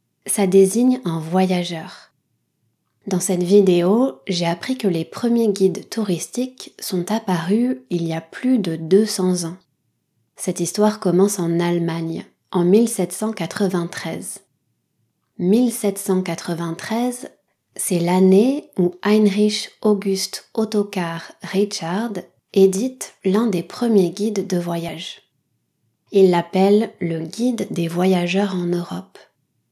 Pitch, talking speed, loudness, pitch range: 190 Hz, 105 wpm, -19 LUFS, 175-210 Hz